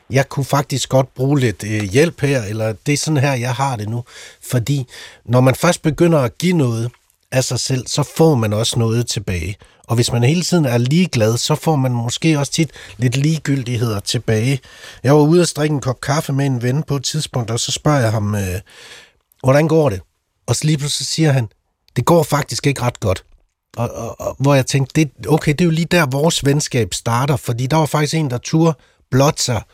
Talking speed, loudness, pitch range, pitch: 225 wpm, -17 LUFS, 120-150 Hz, 135 Hz